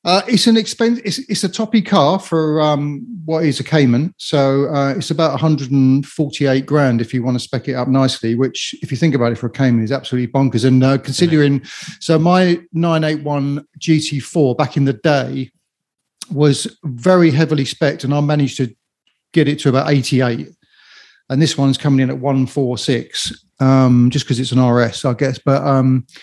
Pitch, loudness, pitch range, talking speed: 140 Hz, -16 LUFS, 130-160 Hz, 190 wpm